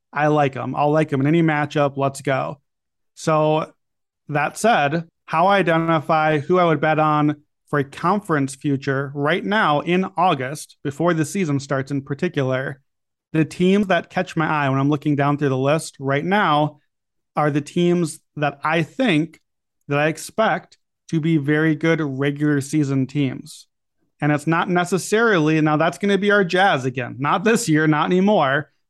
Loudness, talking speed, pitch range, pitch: -20 LUFS, 175 wpm, 145-170 Hz, 155 Hz